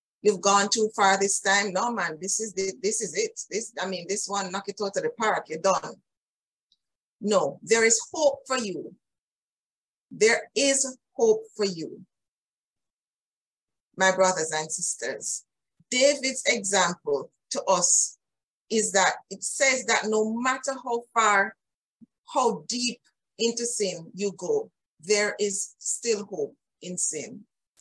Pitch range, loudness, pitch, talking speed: 195-255 Hz, -25 LUFS, 215 Hz, 145 wpm